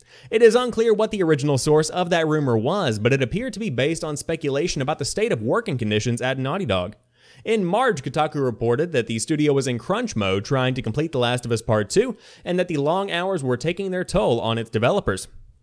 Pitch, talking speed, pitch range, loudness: 145 Hz, 230 wpm, 120-180 Hz, -22 LUFS